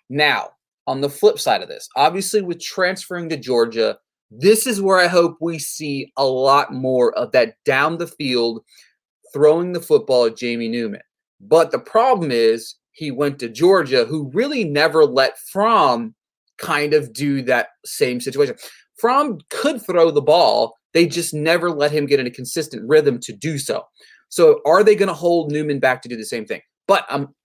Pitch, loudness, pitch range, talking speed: 155 Hz, -18 LUFS, 135-185 Hz, 190 wpm